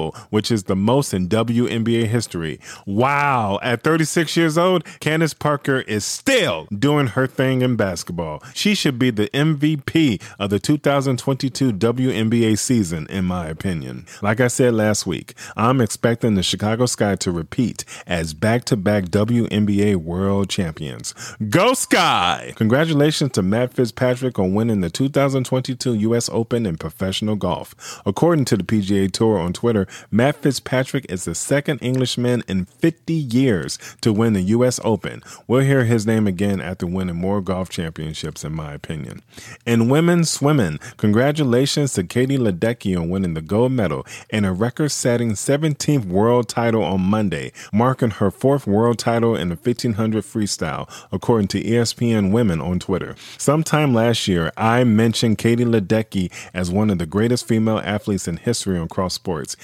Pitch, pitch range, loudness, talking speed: 115 Hz, 100-130 Hz, -19 LUFS, 155 wpm